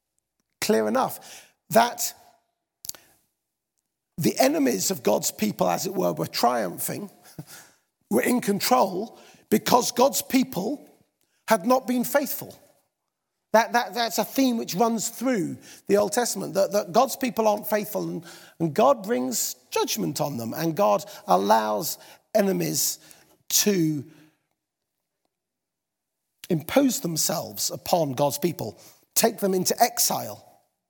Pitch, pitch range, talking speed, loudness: 215 Hz, 180-245 Hz, 120 wpm, -24 LUFS